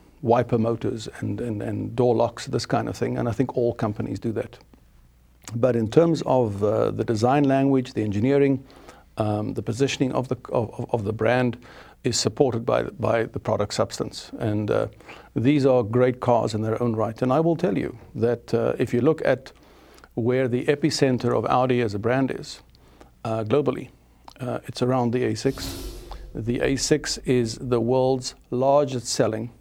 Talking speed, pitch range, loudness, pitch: 180 wpm, 115-135 Hz, -24 LUFS, 125 Hz